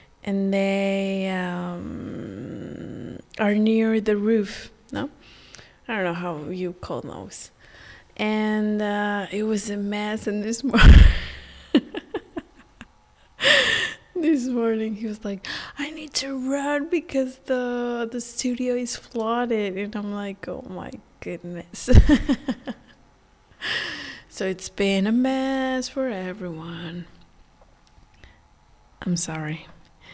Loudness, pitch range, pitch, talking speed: -24 LUFS, 180-250 Hz, 210 Hz, 110 wpm